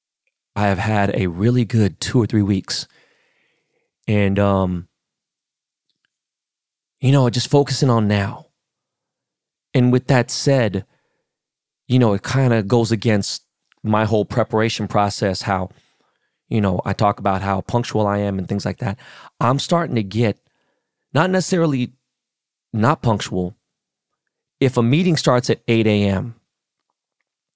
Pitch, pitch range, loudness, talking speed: 110 Hz, 100-125 Hz, -19 LUFS, 135 wpm